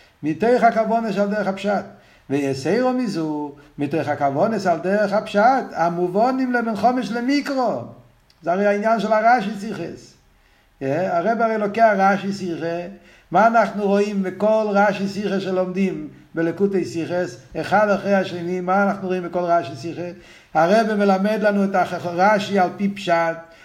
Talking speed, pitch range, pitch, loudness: 135 wpm, 170-210 Hz, 195 Hz, -20 LUFS